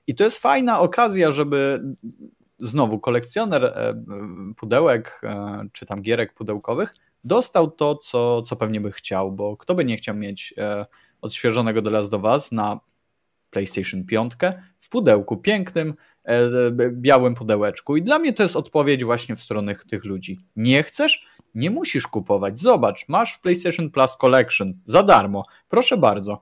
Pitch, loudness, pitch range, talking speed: 120 Hz, -20 LUFS, 105-155 Hz, 155 wpm